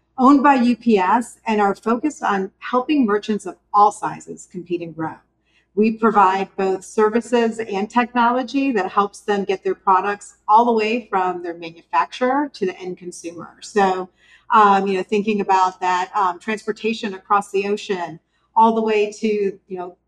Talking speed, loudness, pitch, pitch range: 165 wpm, -19 LUFS, 205 Hz, 190-225 Hz